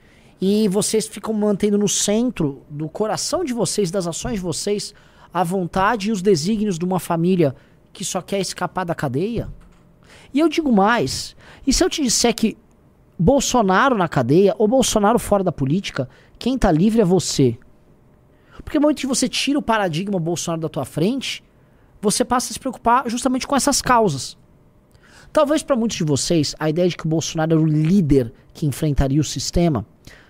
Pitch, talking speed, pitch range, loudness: 195 Hz, 180 wpm, 160-230 Hz, -19 LUFS